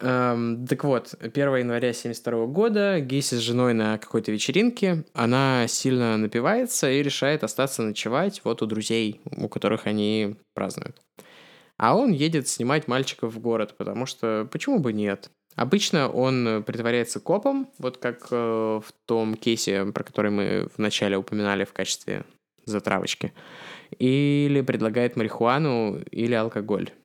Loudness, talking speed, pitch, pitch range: -25 LUFS, 135 wpm, 120 Hz, 110-135 Hz